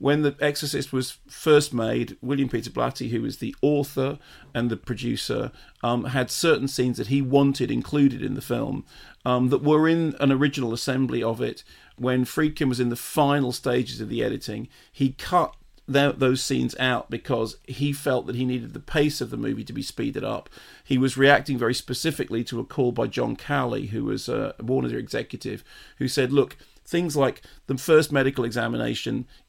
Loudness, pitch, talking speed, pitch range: -25 LUFS, 130 Hz, 190 wpm, 125-140 Hz